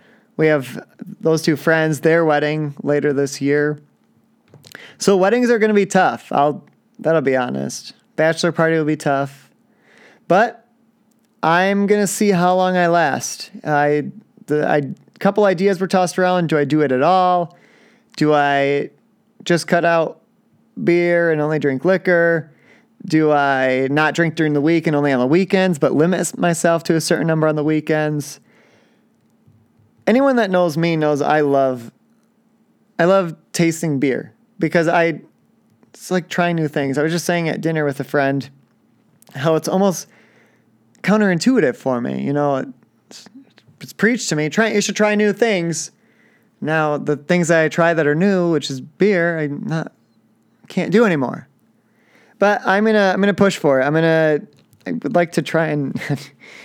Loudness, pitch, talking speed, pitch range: -17 LUFS, 165 Hz, 170 wpm, 150-195 Hz